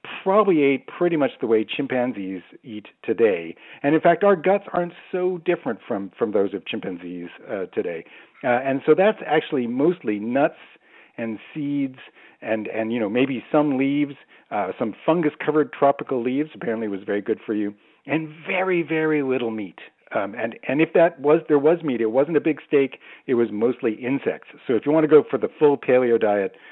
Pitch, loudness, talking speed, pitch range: 140 Hz, -22 LUFS, 190 wpm, 115-160 Hz